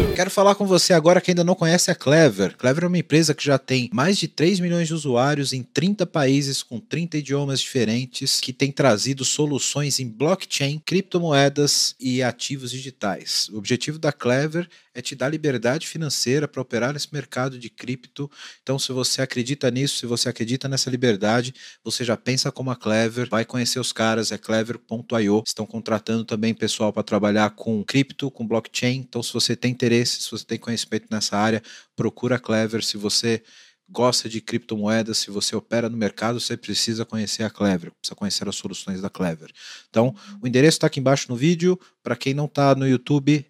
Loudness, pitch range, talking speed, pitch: -22 LUFS, 115-145 Hz, 190 wpm, 125 Hz